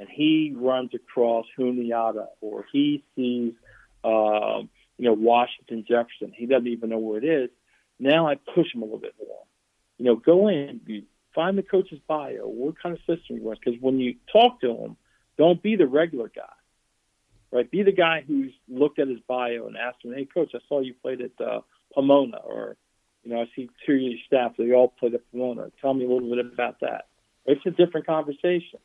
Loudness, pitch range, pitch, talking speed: -24 LUFS, 120-160 Hz, 130 Hz, 205 wpm